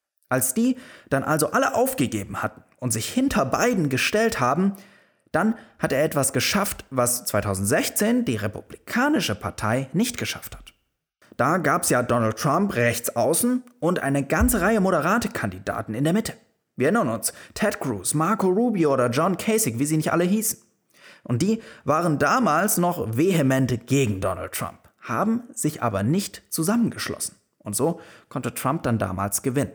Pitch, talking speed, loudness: 150 Hz, 160 wpm, -23 LUFS